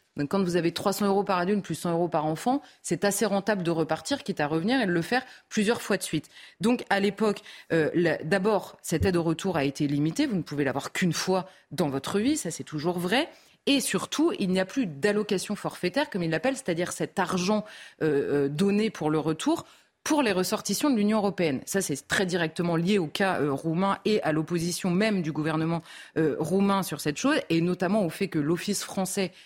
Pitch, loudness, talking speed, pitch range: 185 Hz, -27 LUFS, 220 wpm, 165-210 Hz